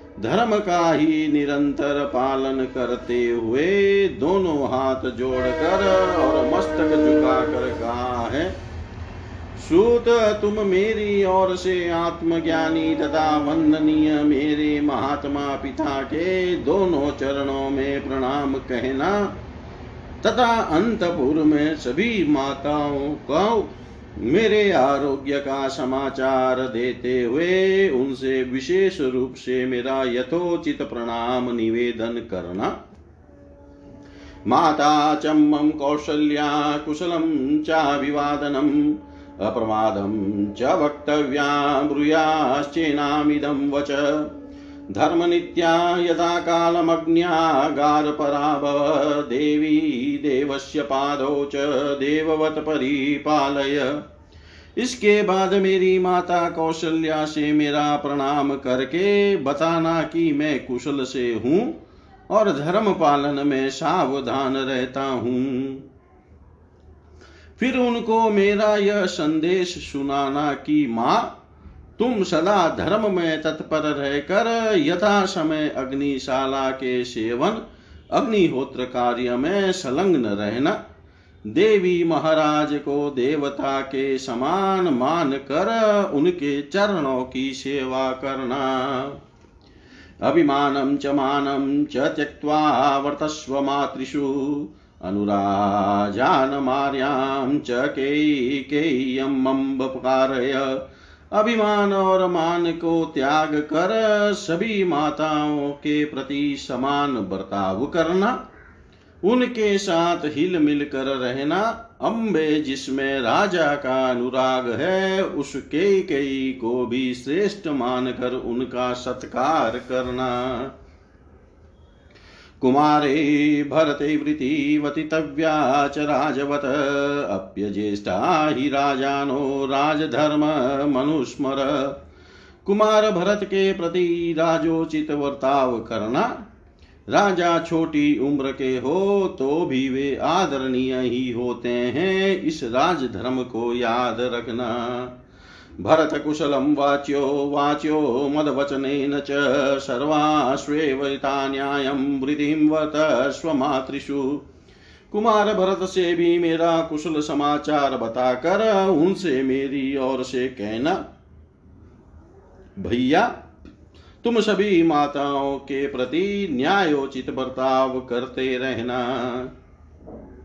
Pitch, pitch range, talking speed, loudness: 145 Hz, 130-160 Hz, 85 wpm, -21 LUFS